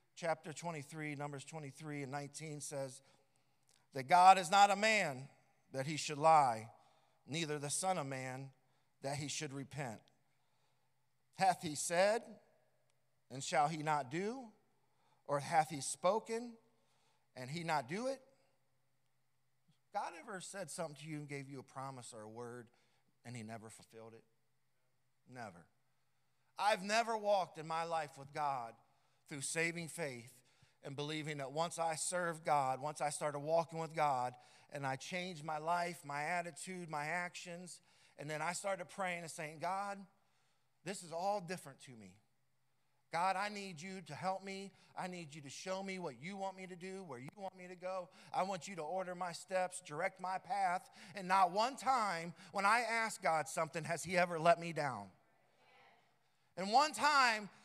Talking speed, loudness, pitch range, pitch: 170 wpm, -38 LUFS, 140-185 Hz, 160 Hz